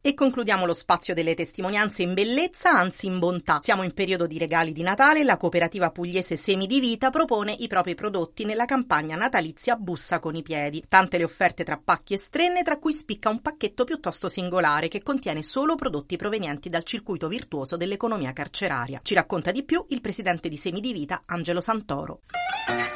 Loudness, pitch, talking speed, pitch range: -25 LUFS, 190 Hz, 190 wpm, 170-235 Hz